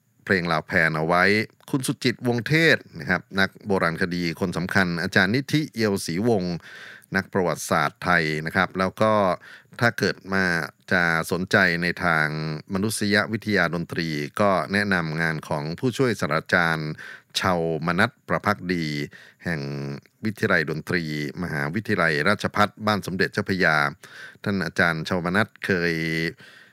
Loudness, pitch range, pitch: -23 LUFS, 80-105 Hz, 90 Hz